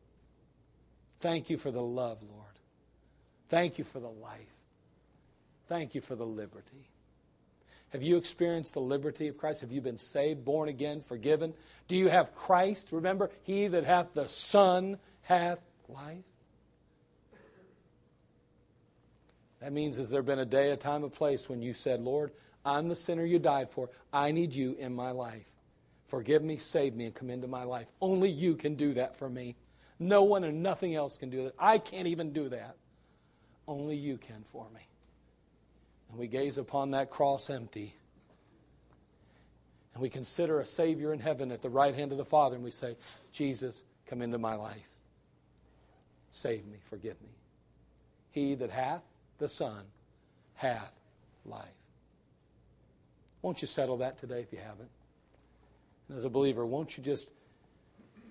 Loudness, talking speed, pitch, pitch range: -33 LUFS, 165 wpm, 135 Hz, 110-155 Hz